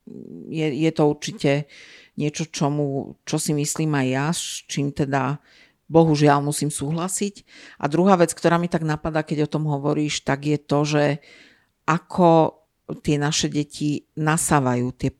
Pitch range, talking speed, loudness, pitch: 145-160 Hz, 150 wpm, -22 LUFS, 150 Hz